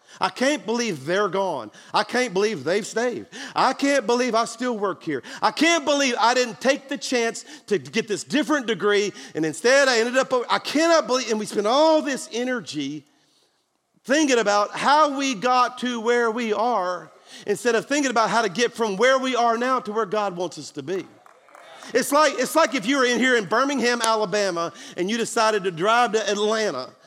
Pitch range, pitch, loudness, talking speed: 210-260 Hz, 235 Hz, -22 LUFS, 200 wpm